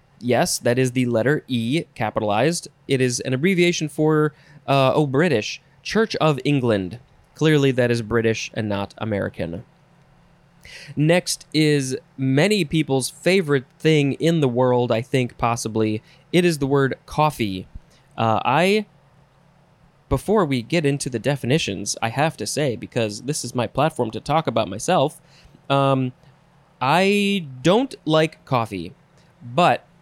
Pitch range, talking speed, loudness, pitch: 125-160 Hz, 140 wpm, -21 LUFS, 145 Hz